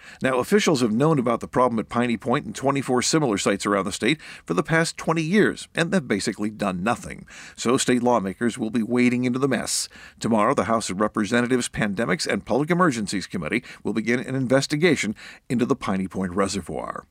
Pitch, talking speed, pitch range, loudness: 125 Hz, 195 wpm, 110-140 Hz, -23 LUFS